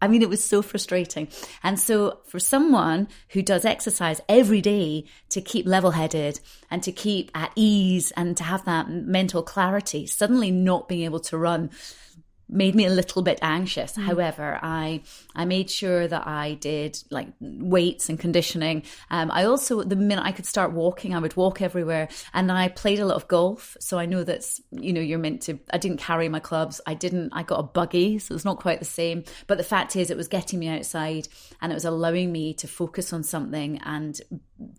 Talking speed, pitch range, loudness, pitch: 205 wpm, 160-190 Hz, -24 LUFS, 175 Hz